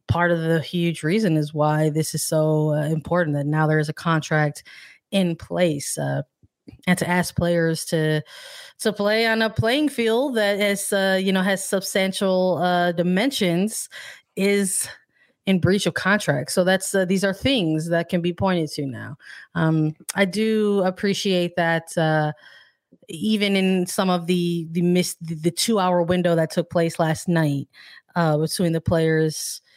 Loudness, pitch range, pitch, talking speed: -22 LUFS, 160-195 Hz, 175 Hz, 165 wpm